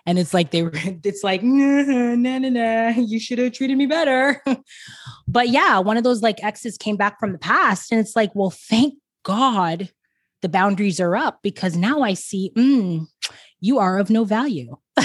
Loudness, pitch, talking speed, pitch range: -20 LUFS, 220 Hz, 190 wpm, 190-255 Hz